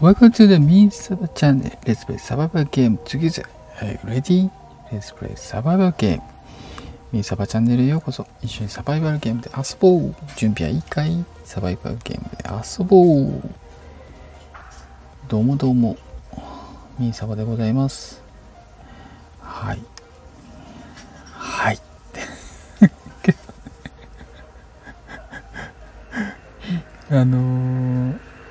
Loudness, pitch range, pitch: -19 LUFS, 105-155 Hz, 125 Hz